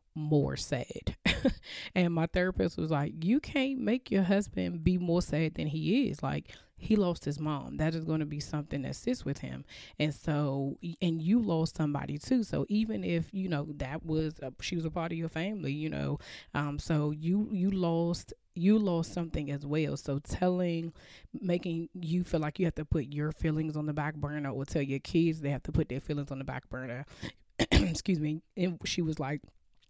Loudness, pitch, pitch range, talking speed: -32 LUFS, 160 Hz, 145-180 Hz, 205 wpm